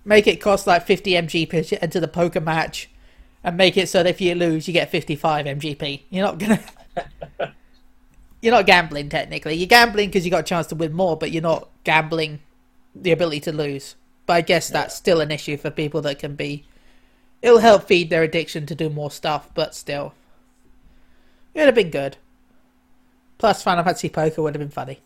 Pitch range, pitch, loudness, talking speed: 155-185 Hz, 165 Hz, -19 LUFS, 200 wpm